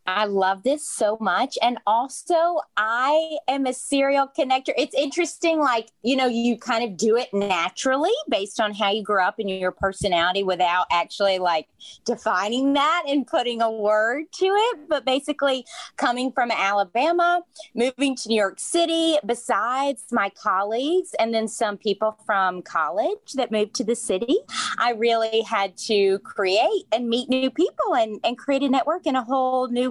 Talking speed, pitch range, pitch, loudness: 170 wpm, 210-285 Hz, 245 Hz, -22 LUFS